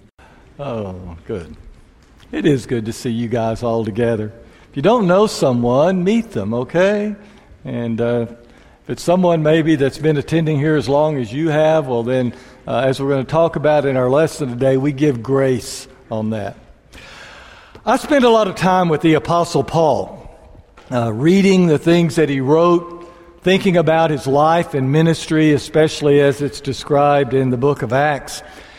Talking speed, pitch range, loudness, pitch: 175 wpm, 130-165 Hz, -16 LUFS, 145 Hz